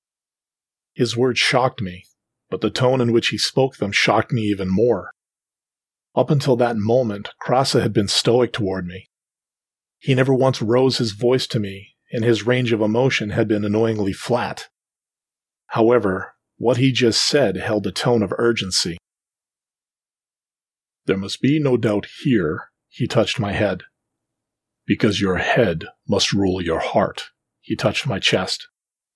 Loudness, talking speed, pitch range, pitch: -19 LUFS, 150 wpm, 100-125 Hz, 115 Hz